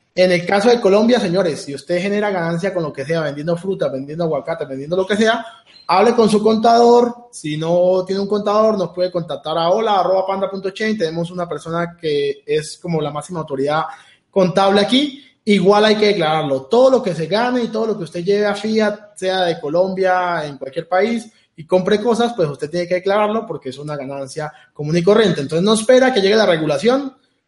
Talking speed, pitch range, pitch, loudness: 200 wpm, 165-220 Hz, 190 Hz, -17 LUFS